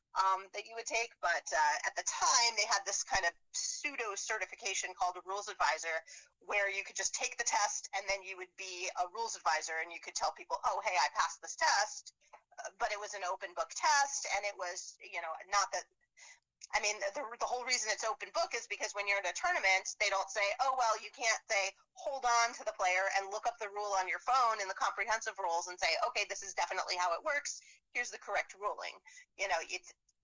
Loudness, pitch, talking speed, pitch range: -35 LUFS, 205 Hz, 235 wpm, 190-240 Hz